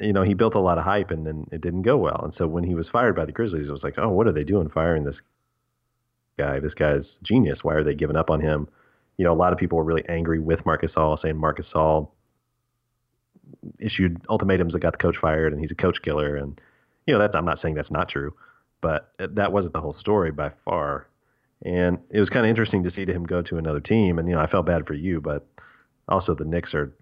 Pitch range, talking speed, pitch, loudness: 80-100 Hz, 255 wpm, 85 Hz, -23 LUFS